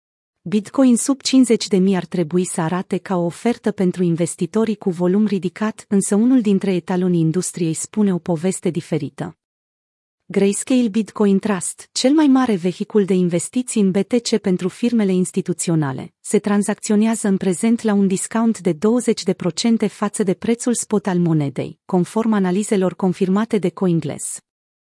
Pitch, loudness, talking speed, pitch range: 195 Hz, -19 LUFS, 140 wpm, 180-220 Hz